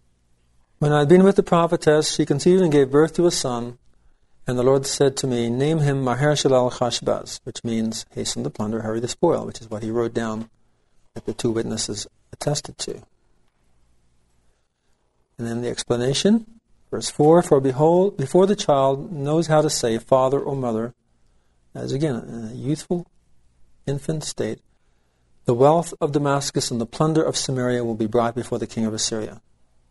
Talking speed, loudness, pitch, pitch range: 175 wpm, -21 LUFS, 125 Hz, 110-150 Hz